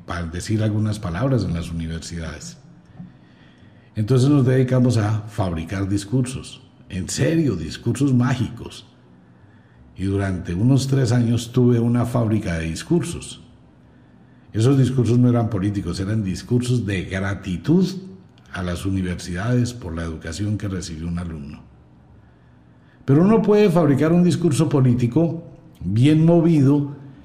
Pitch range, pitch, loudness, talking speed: 90-130 Hz, 110 Hz, -20 LUFS, 120 wpm